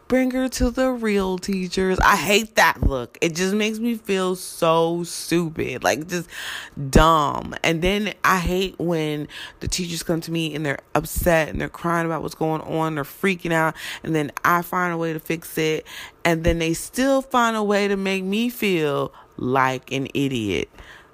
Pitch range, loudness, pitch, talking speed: 160-195 Hz, -22 LUFS, 170 Hz, 185 wpm